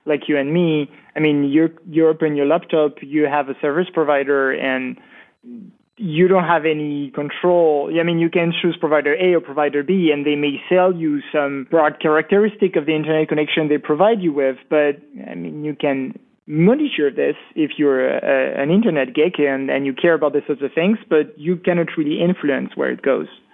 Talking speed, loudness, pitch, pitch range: 200 wpm, -18 LUFS, 155 Hz, 145-175 Hz